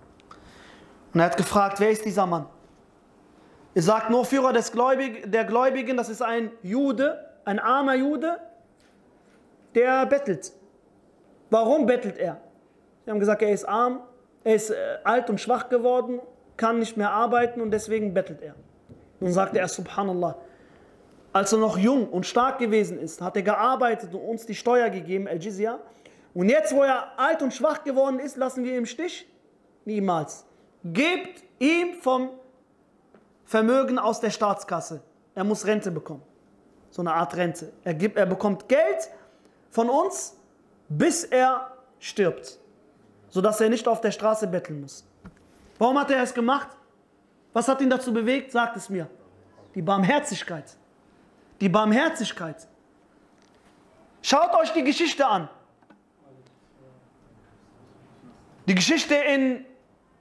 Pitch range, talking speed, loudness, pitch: 195-260 Hz, 145 wpm, -24 LUFS, 230 Hz